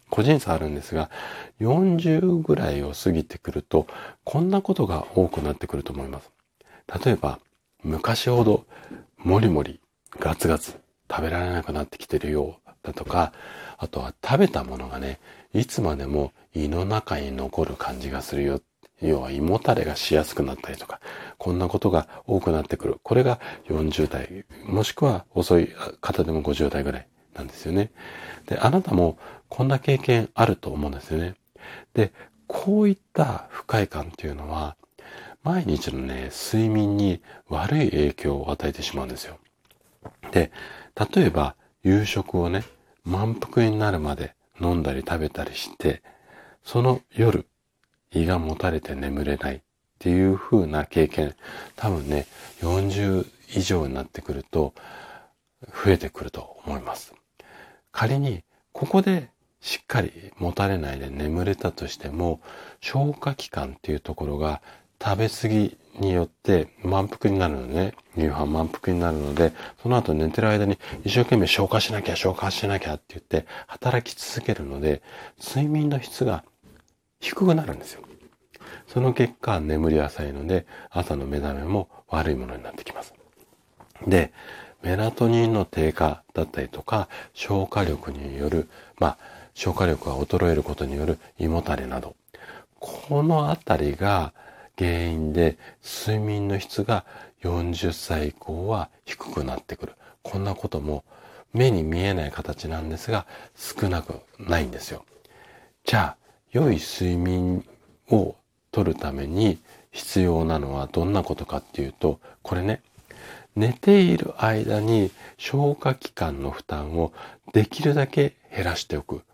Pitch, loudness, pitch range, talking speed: 85 Hz, -25 LUFS, 75-105 Hz, 280 characters per minute